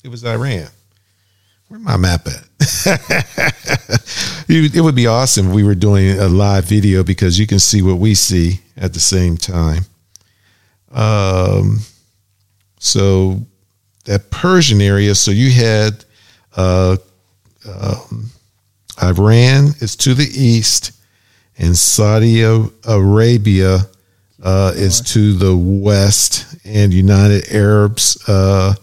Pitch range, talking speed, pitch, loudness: 95-110 Hz, 115 wpm, 100 Hz, -12 LUFS